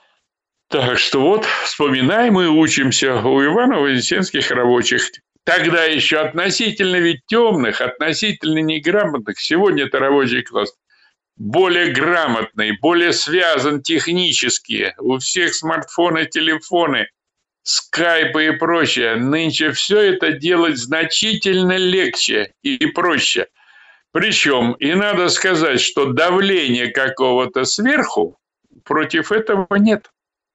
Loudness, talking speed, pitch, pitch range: -16 LUFS, 100 wpm, 160 Hz, 140-190 Hz